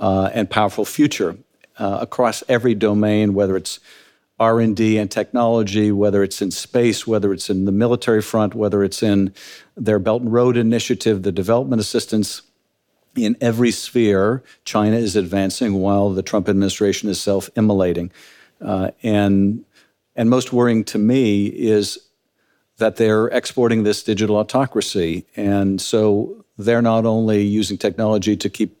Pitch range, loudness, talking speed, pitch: 100-115 Hz, -18 LUFS, 145 wpm, 105 Hz